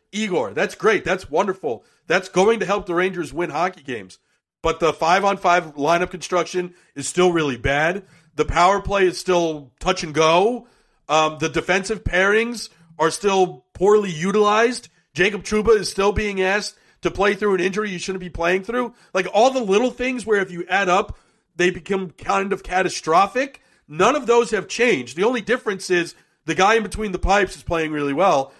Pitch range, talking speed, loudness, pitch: 170-210 Hz, 190 wpm, -20 LUFS, 185 Hz